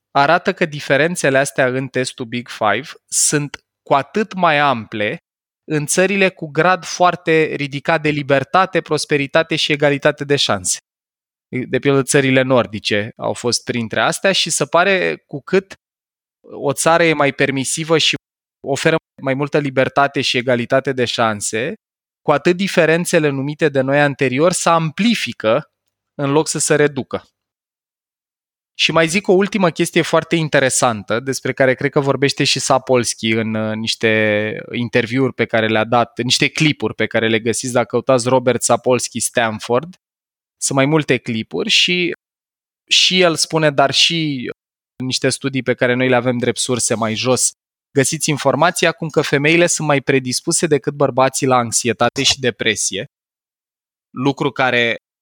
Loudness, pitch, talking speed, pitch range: -16 LUFS, 140 Hz, 150 wpm, 125-160 Hz